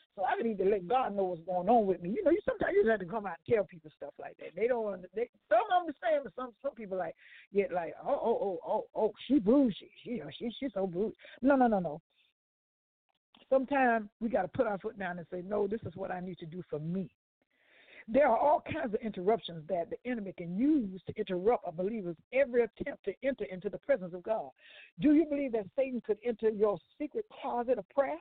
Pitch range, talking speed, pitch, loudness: 185-260 Hz, 240 wpm, 220 Hz, -32 LUFS